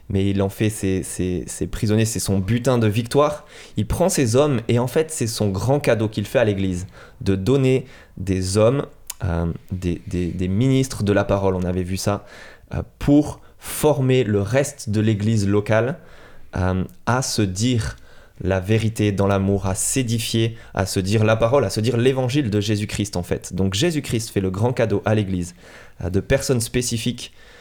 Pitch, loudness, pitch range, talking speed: 110 Hz, -21 LUFS, 95-125 Hz, 190 wpm